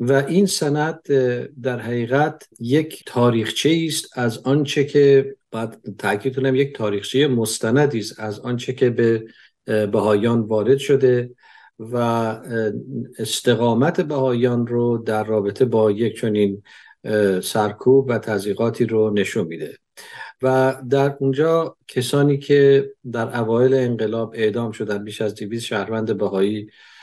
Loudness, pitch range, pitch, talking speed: -20 LUFS, 110-135 Hz, 120 Hz, 120 wpm